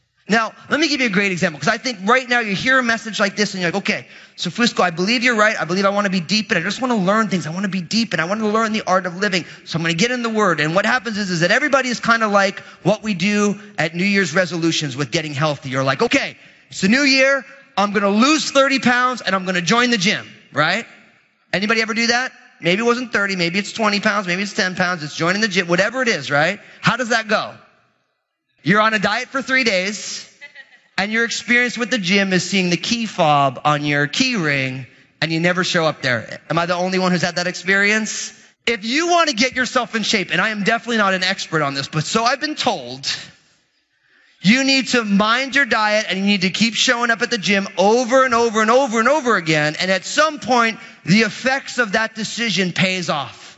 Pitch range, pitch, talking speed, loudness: 180-235 Hz, 205 Hz, 255 wpm, -17 LUFS